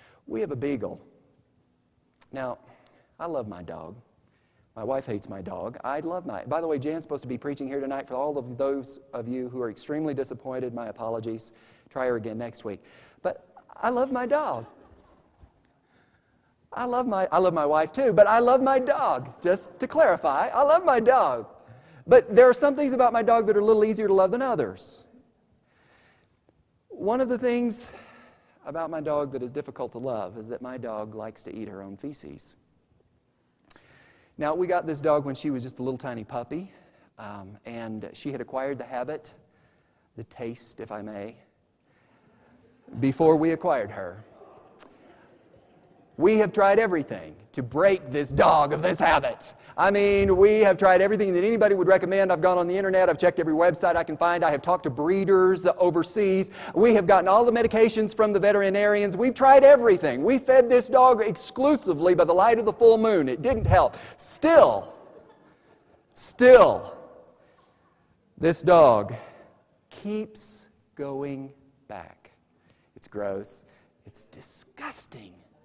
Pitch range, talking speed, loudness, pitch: 130-215 Hz, 170 wpm, -22 LUFS, 175 Hz